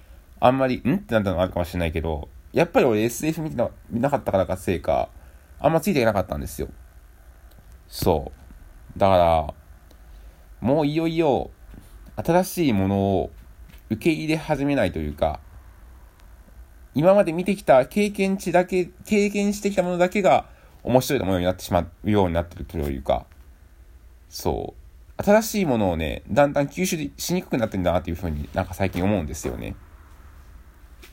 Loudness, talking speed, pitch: -23 LUFS, 345 characters per minute, 90 Hz